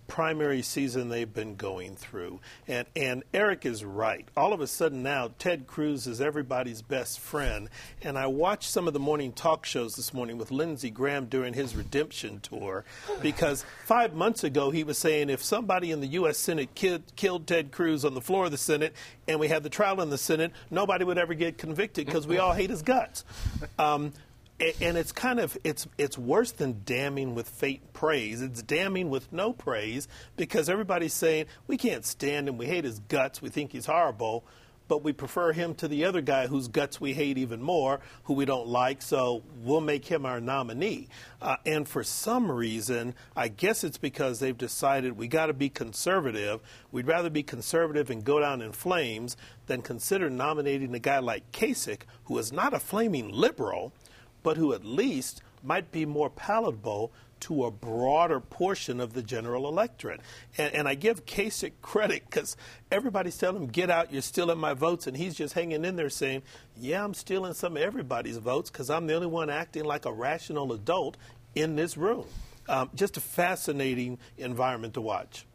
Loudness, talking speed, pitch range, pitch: -30 LUFS, 195 wpm, 125-165 Hz, 145 Hz